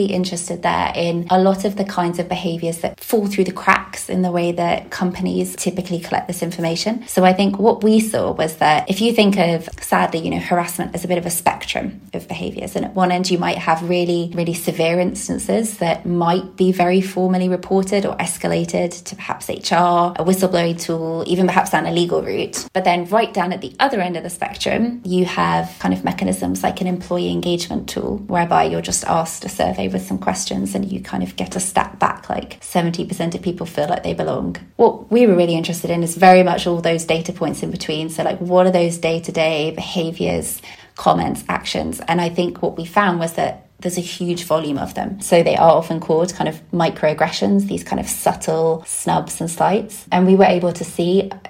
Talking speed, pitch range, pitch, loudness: 215 wpm, 165-185 Hz, 175 Hz, -18 LUFS